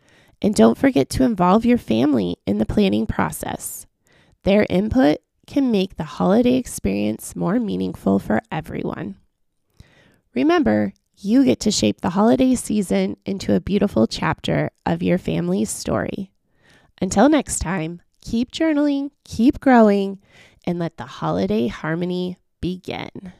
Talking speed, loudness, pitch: 130 wpm, -20 LUFS, 185 Hz